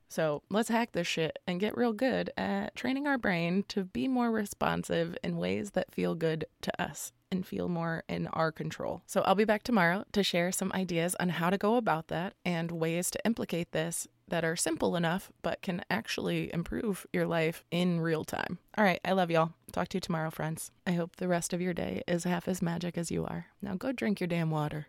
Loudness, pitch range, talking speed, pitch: -32 LUFS, 165-200 Hz, 225 wpm, 175 Hz